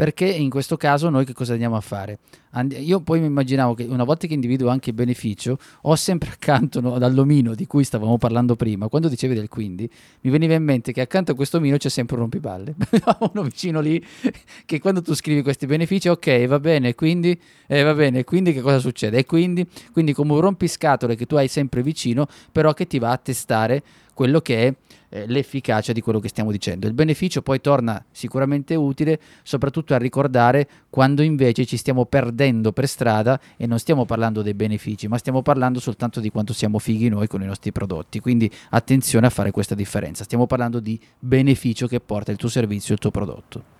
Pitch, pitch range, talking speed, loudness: 130 Hz, 115-150 Hz, 205 wpm, -20 LUFS